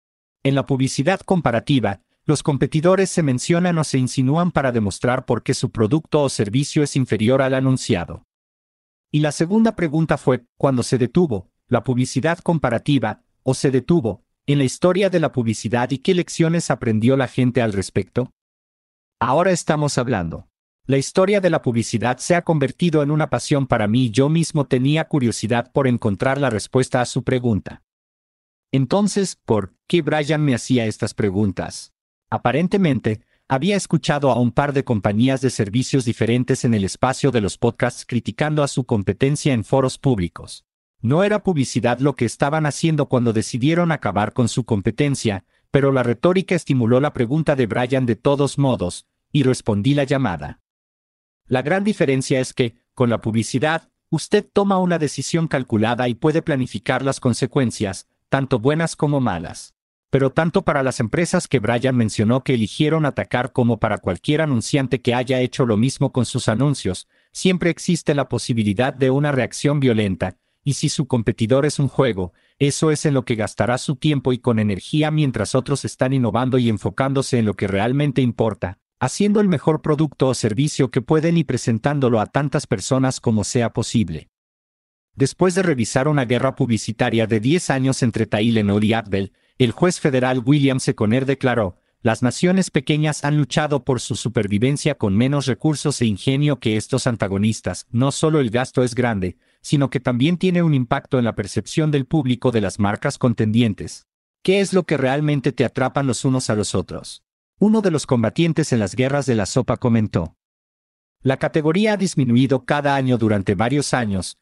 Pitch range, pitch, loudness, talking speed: 115-145 Hz, 130 Hz, -19 LUFS, 170 wpm